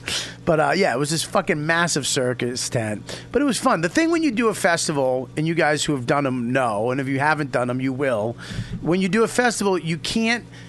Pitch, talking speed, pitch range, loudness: 155 Hz, 245 wpm, 135-190 Hz, -21 LUFS